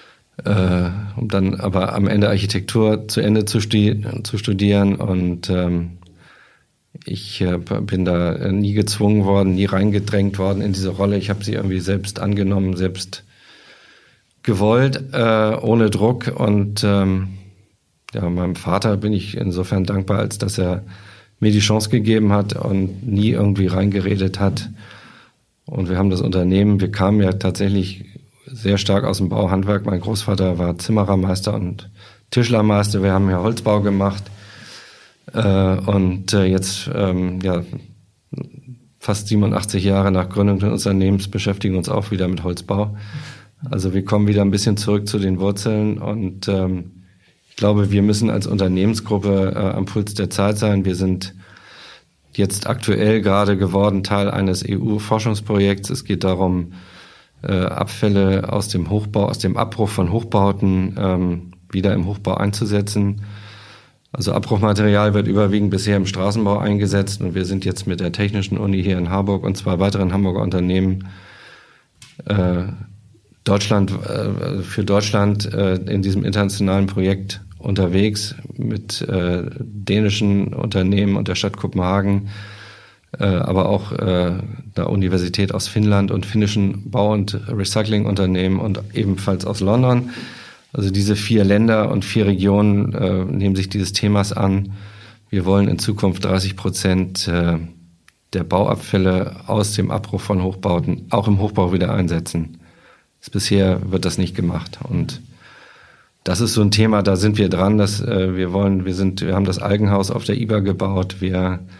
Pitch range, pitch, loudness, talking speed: 95-105 Hz, 100 Hz, -19 LUFS, 145 wpm